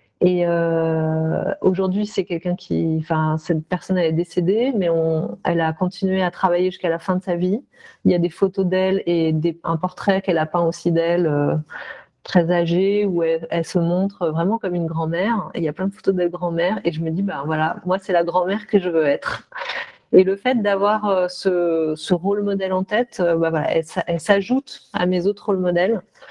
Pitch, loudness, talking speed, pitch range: 180 Hz, -20 LUFS, 210 wpm, 165-195 Hz